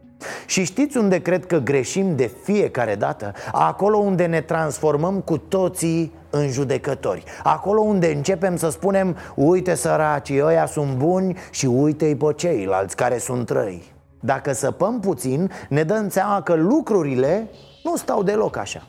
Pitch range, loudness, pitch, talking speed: 145-195 Hz, -21 LUFS, 170 Hz, 145 wpm